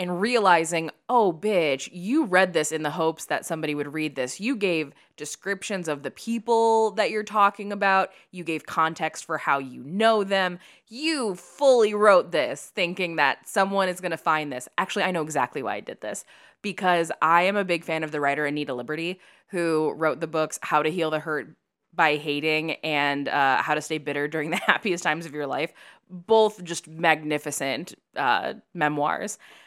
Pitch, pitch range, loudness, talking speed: 165 Hz, 150-195 Hz, -24 LUFS, 185 wpm